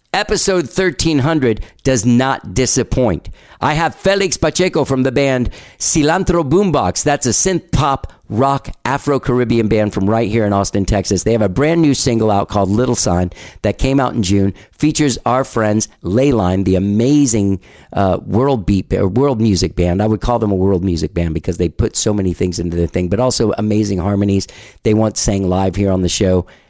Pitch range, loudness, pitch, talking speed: 100-135 Hz, -15 LUFS, 110 Hz, 195 wpm